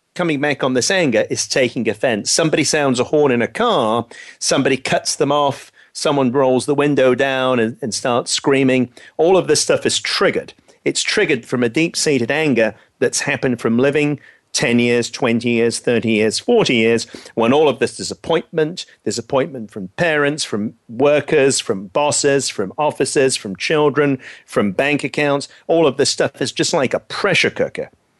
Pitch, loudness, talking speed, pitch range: 140 Hz, -17 LUFS, 175 wpm, 120-150 Hz